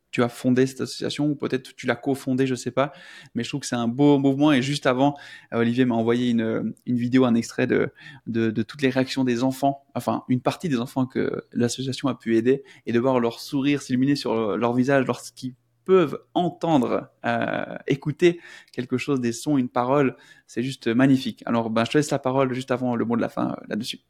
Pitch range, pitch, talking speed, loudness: 120-140 Hz, 130 Hz, 225 wpm, -23 LUFS